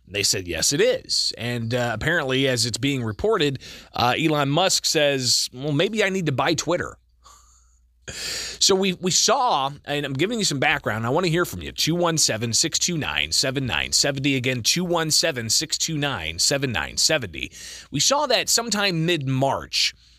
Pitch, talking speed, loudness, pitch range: 145 Hz, 190 wpm, -21 LUFS, 125-170 Hz